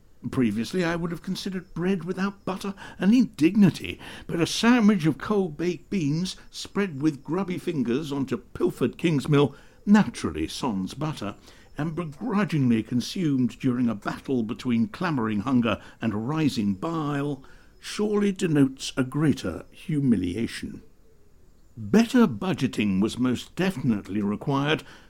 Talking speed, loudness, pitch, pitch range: 120 wpm, -25 LUFS, 145 Hz, 115-185 Hz